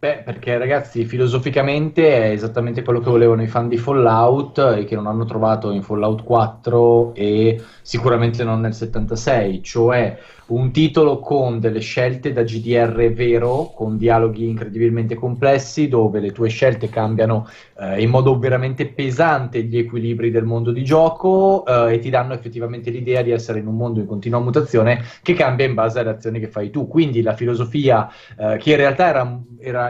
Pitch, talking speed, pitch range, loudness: 120 Hz, 175 wpm, 115-130 Hz, -18 LUFS